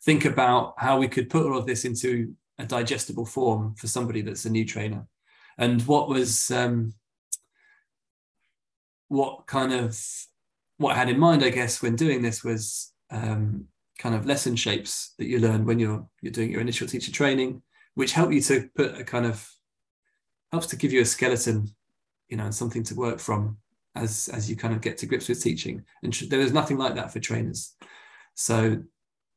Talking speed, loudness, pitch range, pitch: 190 wpm, -26 LUFS, 110-135 Hz, 120 Hz